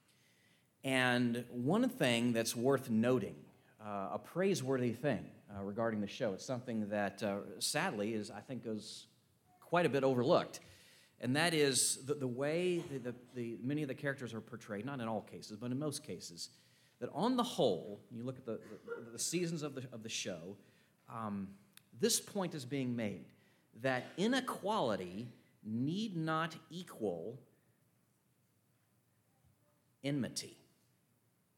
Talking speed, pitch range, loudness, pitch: 150 wpm, 115-150 Hz, -37 LUFS, 125 Hz